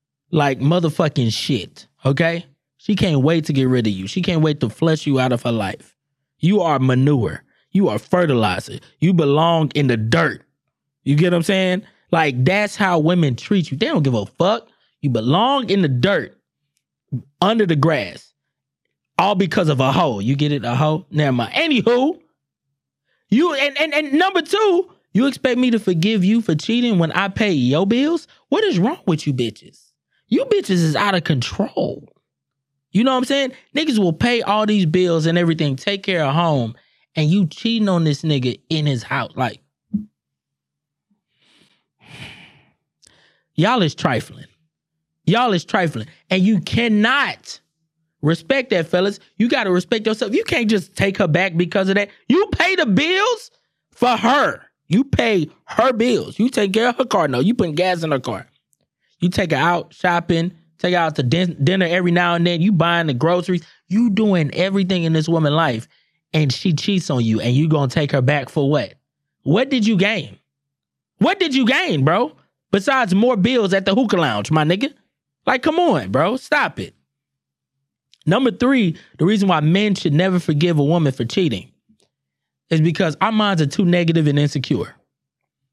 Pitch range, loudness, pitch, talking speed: 145-205 Hz, -18 LUFS, 170 Hz, 185 wpm